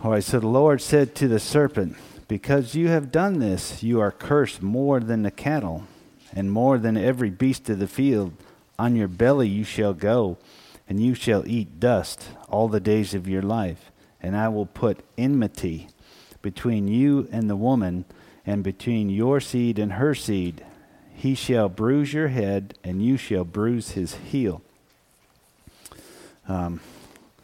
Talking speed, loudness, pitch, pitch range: 165 wpm, -23 LUFS, 110 Hz, 100-130 Hz